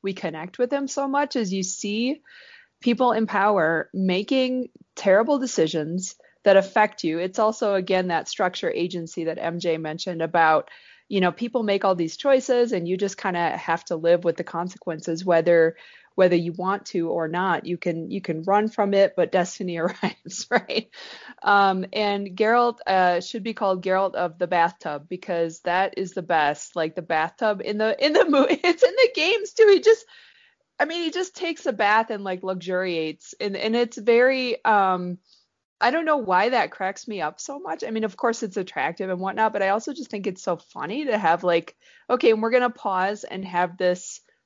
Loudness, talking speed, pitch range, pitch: -23 LUFS, 195 wpm, 175-240 Hz, 195 Hz